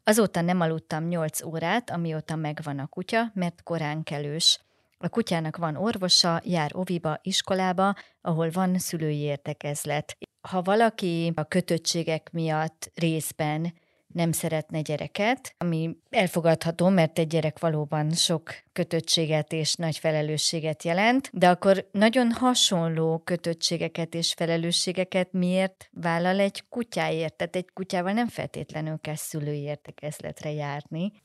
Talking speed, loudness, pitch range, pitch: 125 wpm, -26 LUFS, 155-185 Hz, 165 Hz